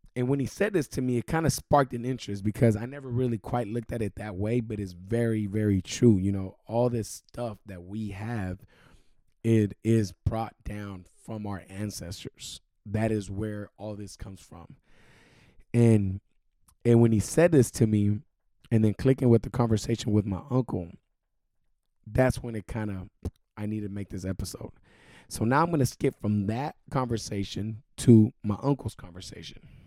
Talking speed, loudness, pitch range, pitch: 185 wpm, -28 LUFS, 100-120 Hz, 110 Hz